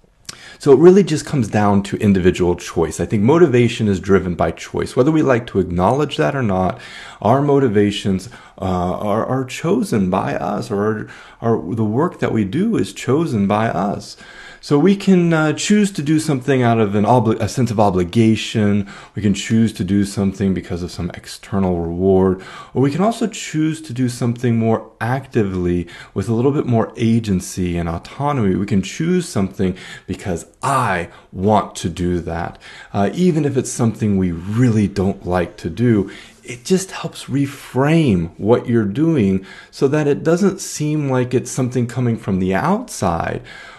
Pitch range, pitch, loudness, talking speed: 95-140 Hz, 115 Hz, -18 LUFS, 175 wpm